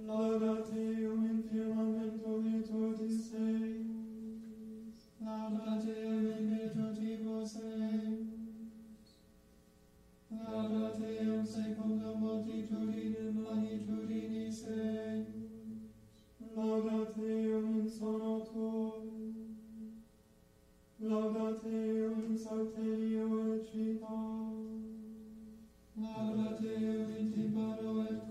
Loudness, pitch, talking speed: -38 LUFS, 220 Hz, 75 wpm